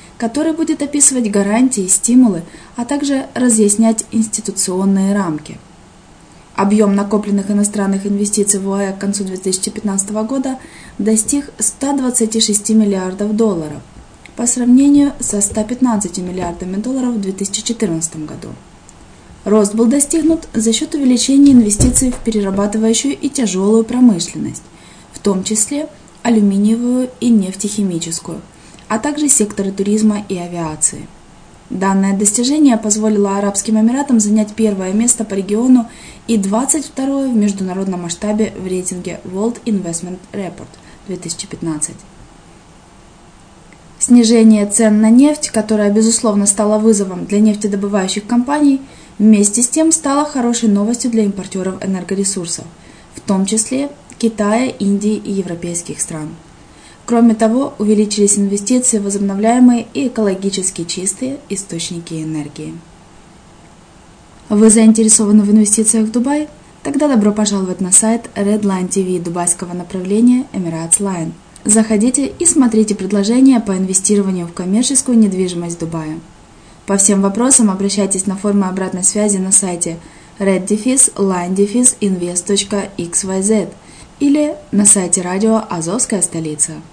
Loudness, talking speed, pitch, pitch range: -14 LUFS, 110 wpm, 210 Hz, 190-235 Hz